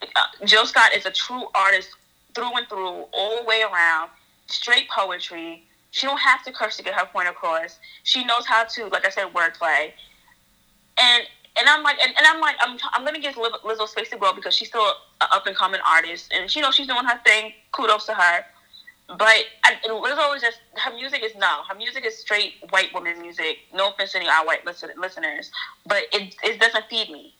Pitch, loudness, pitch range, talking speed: 220 Hz, -20 LUFS, 190-250 Hz, 215 wpm